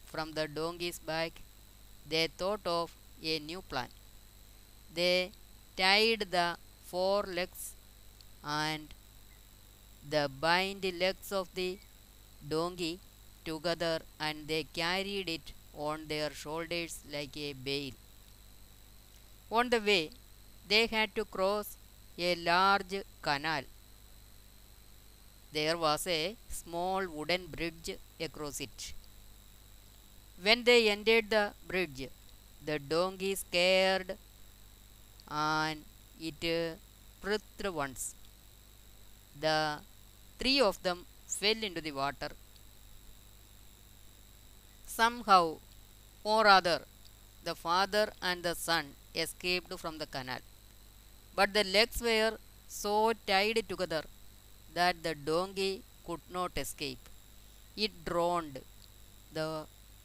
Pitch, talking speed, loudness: 150 Hz, 100 wpm, -32 LUFS